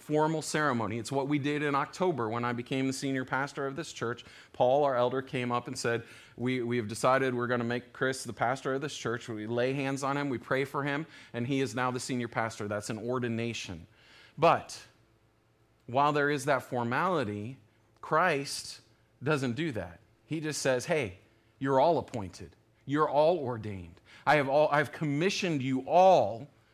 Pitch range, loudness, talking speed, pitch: 115-140 Hz, -30 LUFS, 190 wpm, 125 Hz